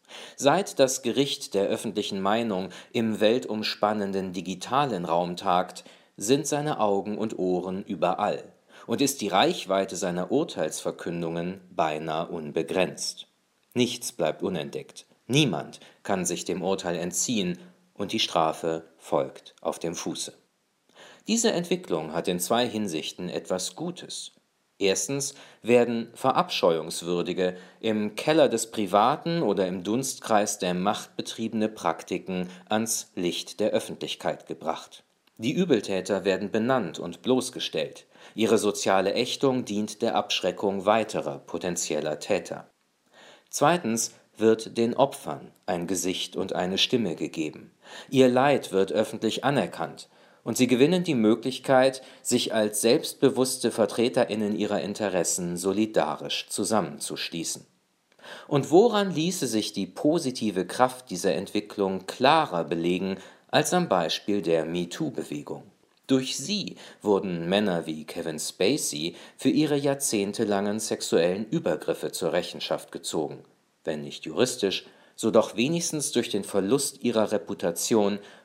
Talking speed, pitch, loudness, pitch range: 120 wpm, 105 Hz, -26 LUFS, 95-130 Hz